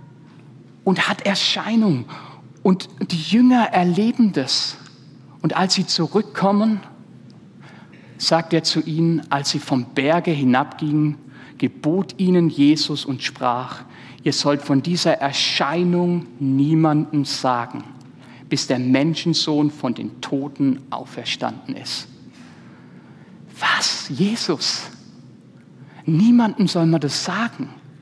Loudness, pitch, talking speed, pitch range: -19 LUFS, 150 Hz, 105 wpm, 140-175 Hz